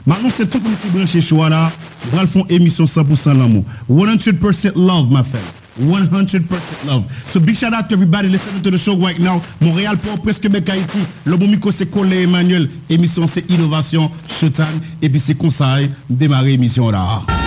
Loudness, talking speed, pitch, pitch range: -14 LUFS, 190 wpm, 170 Hz, 150-190 Hz